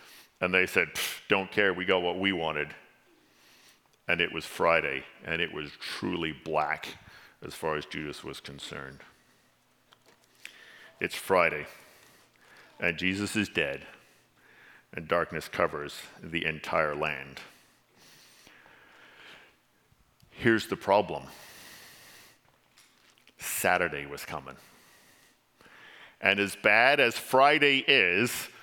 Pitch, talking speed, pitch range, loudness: 90 Hz, 105 wpm, 80-100 Hz, -27 LUFS